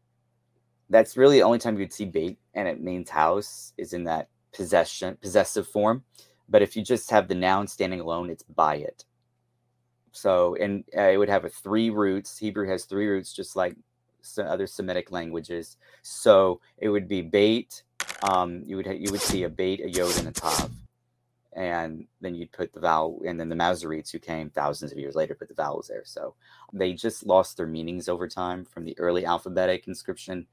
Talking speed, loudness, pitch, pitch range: 200 wpm, -26 LUFS, 95 Hz, 85-105 Hz